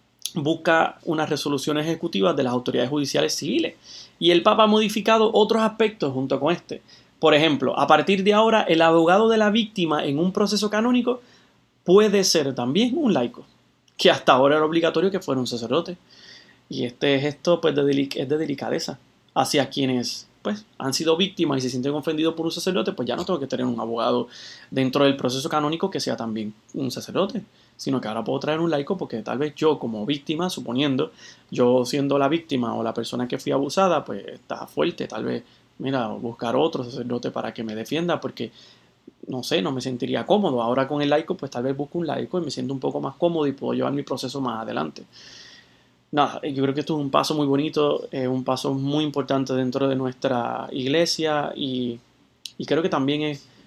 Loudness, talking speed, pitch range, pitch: -23 LUFS, 200 wpm, 130-165 Hz, 145 Hz